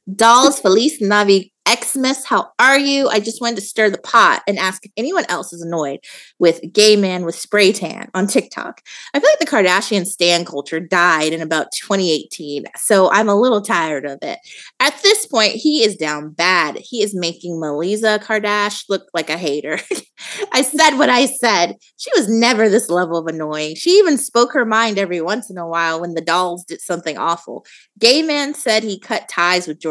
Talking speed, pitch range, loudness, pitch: 200 wpm, 170-235 Hz, -15 LUFS, 200 Hz